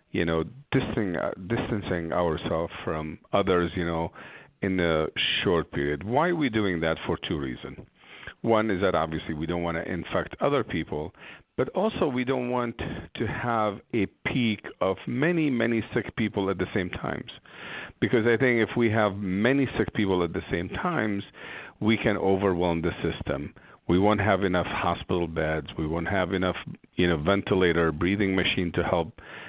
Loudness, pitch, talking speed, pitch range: -27 LUFS, 95 Hz, 175 wpm, 85-115 Hz